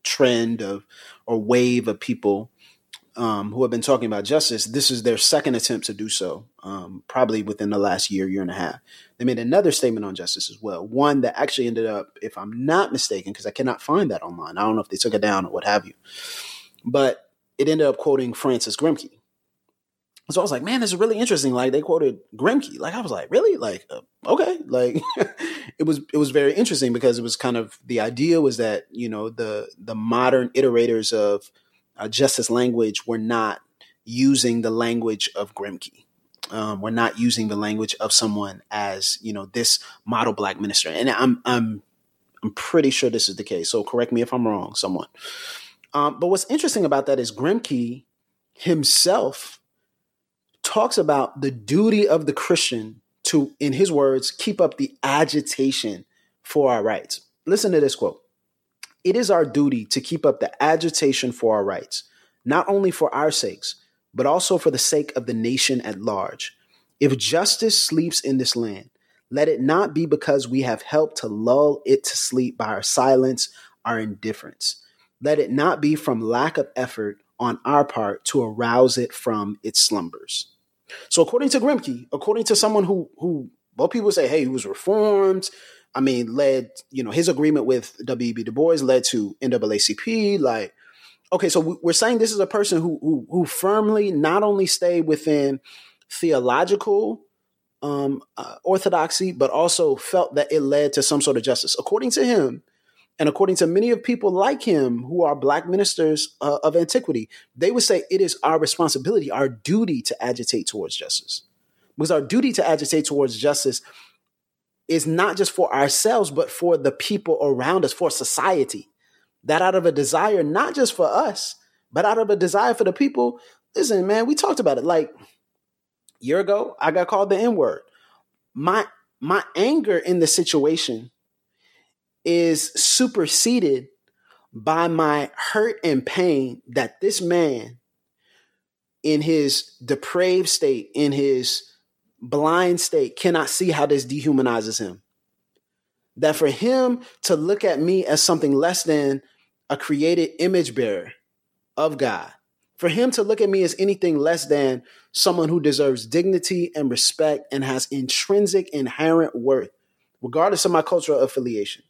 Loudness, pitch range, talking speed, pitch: -21 LUFS, 125-195 Hz, 175 wpm, 150 Hz